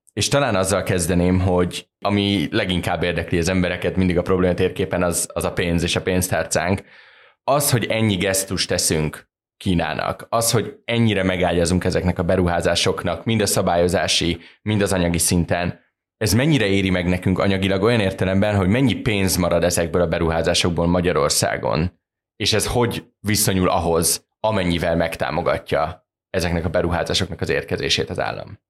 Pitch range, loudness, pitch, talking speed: 85-105 Hz, -20 LUFS, 95 Hz, 150 wpm